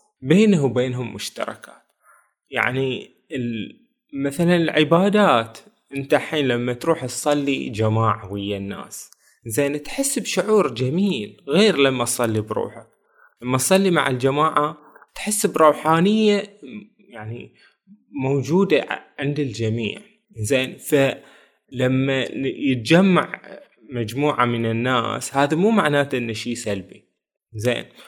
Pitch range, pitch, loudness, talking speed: 120-180 Hz, 140 Hz, -20 LUFS, 95 wpm